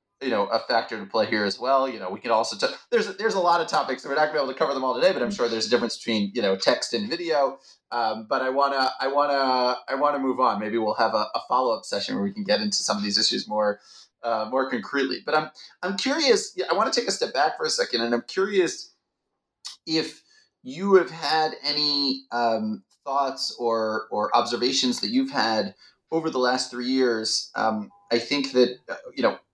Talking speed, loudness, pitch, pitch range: 240 wpm, -24 LUFS, 135 Hz, 120-190 Hz